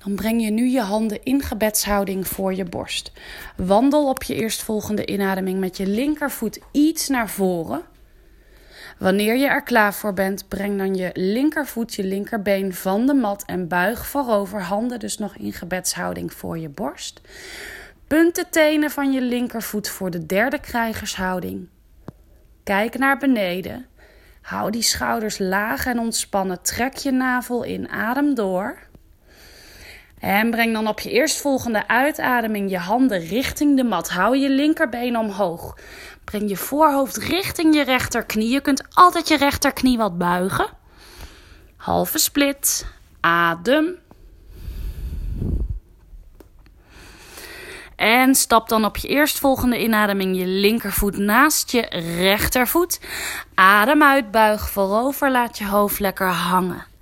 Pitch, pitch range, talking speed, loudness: 215 Hz, 190-265 Hz, 135 wpm, -20 LUFS